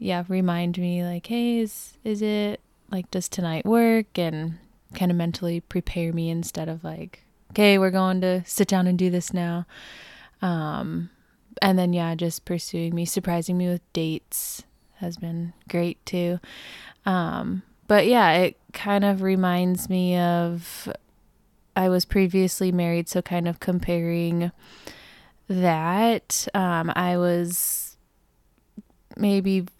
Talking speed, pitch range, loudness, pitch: 135 wpm, 170-195 Hz, -24 LUFS, 180 Hz